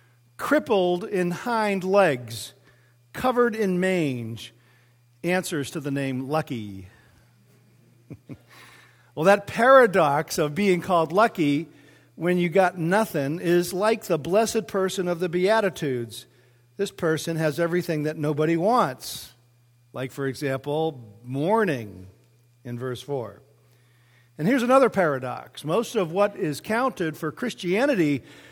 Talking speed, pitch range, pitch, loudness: 120 wpm, 125-190 Hz, 155 Hz, -24 LUFS